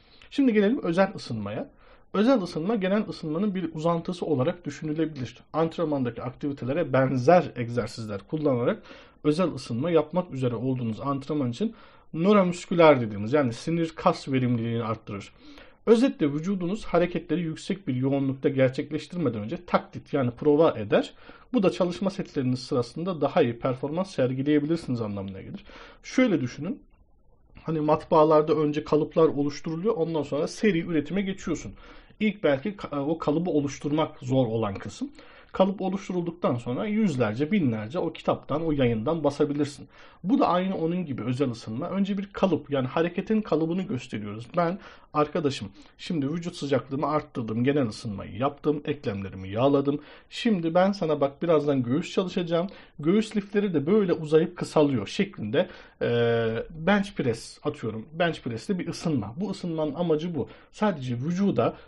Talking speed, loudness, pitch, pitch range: 135 wpm, -26 LUFS, 155 Hz, 130-175 Hz